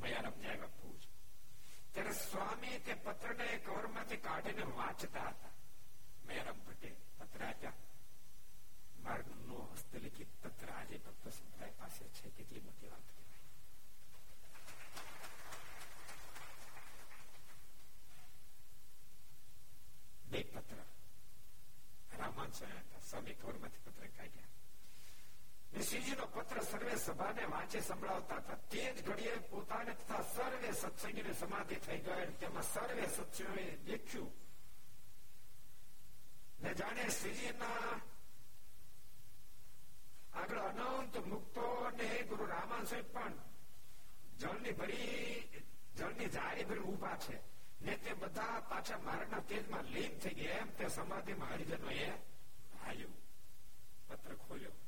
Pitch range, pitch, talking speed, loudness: 200-235 Hz, 230 Hz, 80 wpm, -46 LUFS